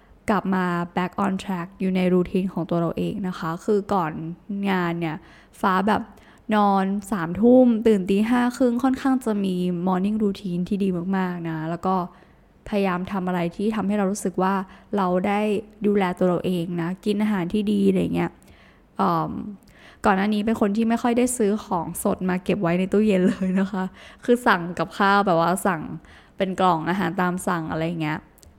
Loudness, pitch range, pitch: -23 LUFS, 180-205 Hz, 190 Hz